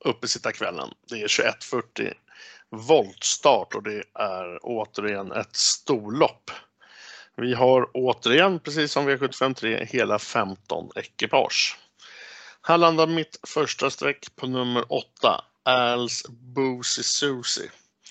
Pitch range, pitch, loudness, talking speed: 120-140 Hz, 125 Hz, -24 LUFS, 105 wpm